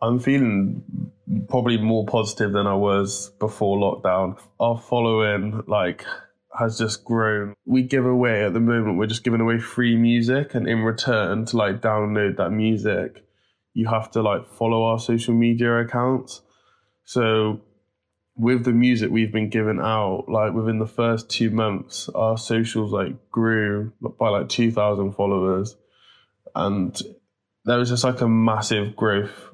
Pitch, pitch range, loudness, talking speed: 110 Hz, 105-115 Hz, -22 LUFS, 150 wpm